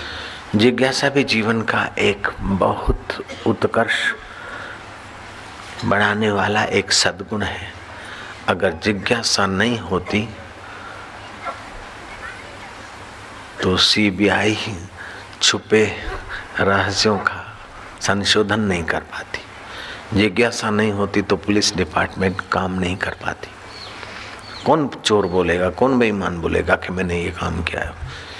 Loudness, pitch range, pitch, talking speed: -19 LUFS, 95-110 Hz, 100 Hz, 100 wpm